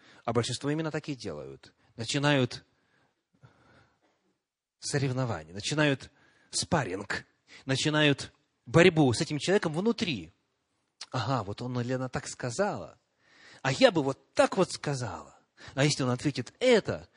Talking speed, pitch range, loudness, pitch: 120 wpm, 120-150 Hz, -29 LUFS, 135 Hz